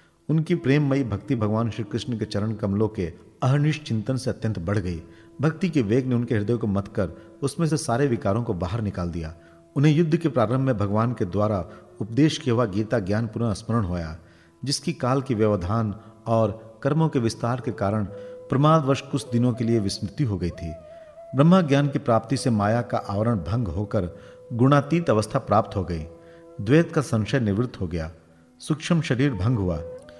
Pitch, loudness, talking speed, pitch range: 115 Hz, -24 LUFS, 185 wpm, 100-135 Hz